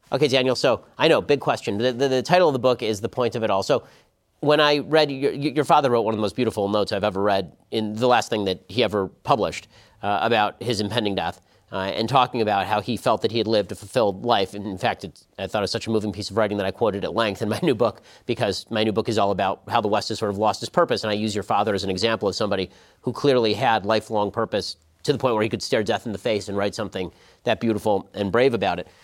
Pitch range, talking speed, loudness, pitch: 100-120 Hz, 285 wpm, -23 LUFS, 110 Hz